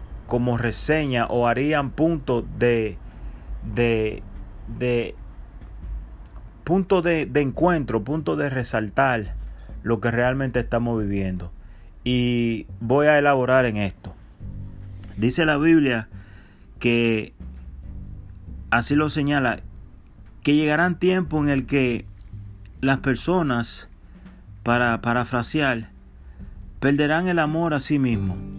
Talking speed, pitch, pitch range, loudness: 105 wpm, 120 Hz, 100-140 Hz, -22 LUFS